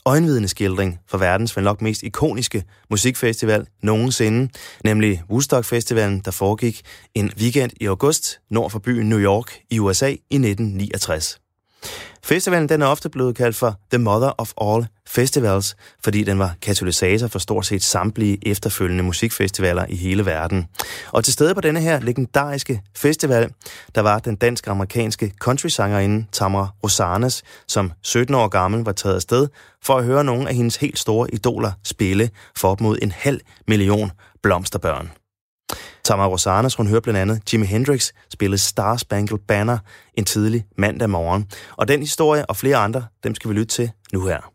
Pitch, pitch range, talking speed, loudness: 110 Hz, 100-120 Hz, 165 wpm, -19 LUFS